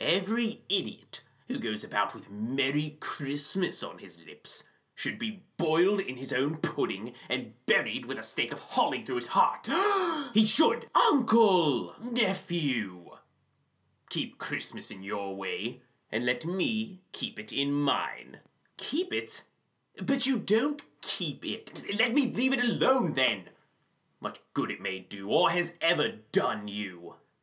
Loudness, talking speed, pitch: -29 LUFS, 145 wpm, 185 Hz